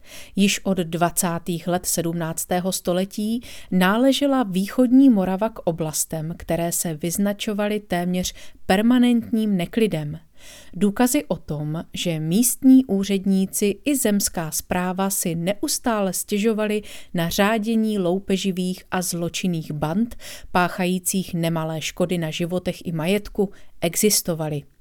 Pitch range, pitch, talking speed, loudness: 175-215 Hz, 190 Hz, 105 wpm, -22 LUFS